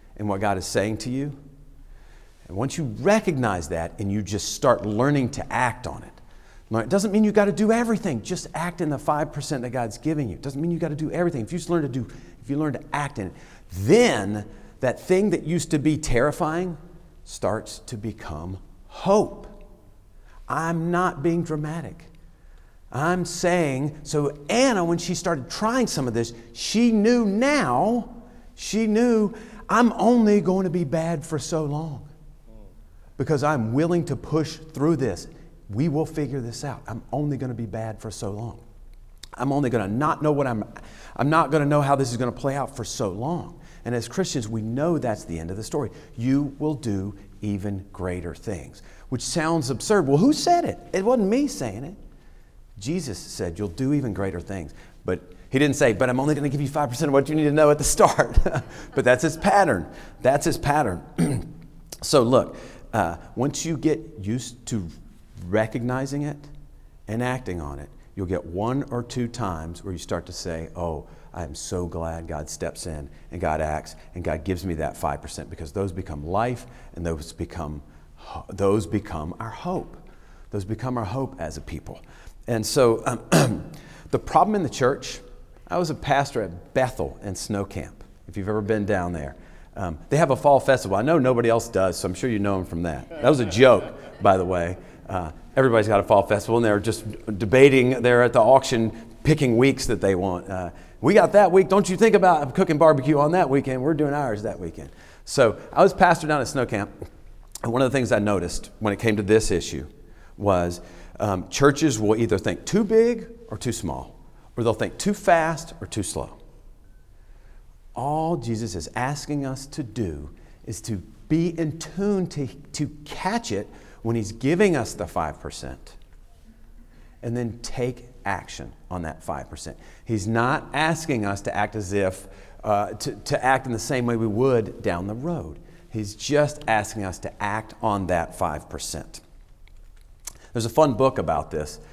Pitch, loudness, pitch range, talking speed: 120 Hz, -23 LUFS, 95-150 Hz, 195 wpm